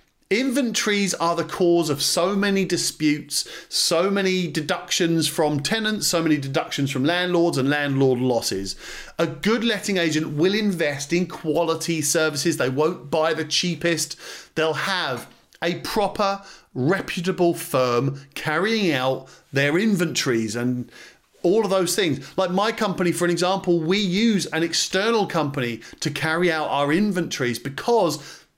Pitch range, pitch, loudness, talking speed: 150-190 Hz, 170 Hz, -22 LUFS, 140 wpm